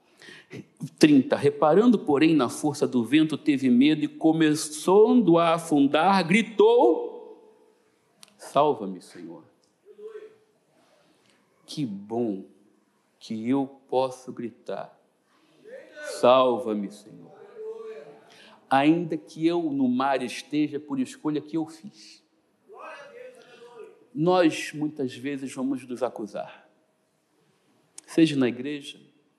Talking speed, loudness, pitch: 90 wpm, -23 LUFS, 160 Hz